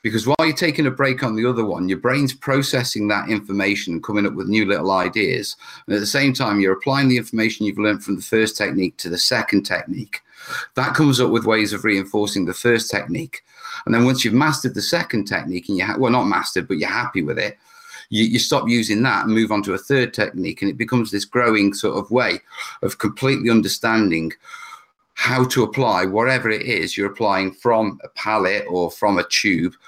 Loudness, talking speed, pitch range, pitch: -19 LUFS, 215 wpm, 100-130 Hz, 110 Hz